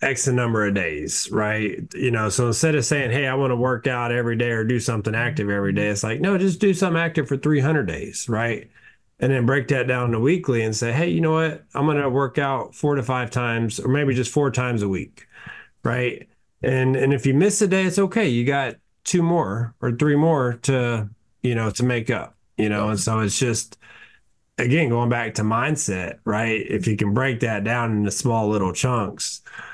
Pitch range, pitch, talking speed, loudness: 110-140 Hz, 125 Hz, 220 wpm, -22 LUFS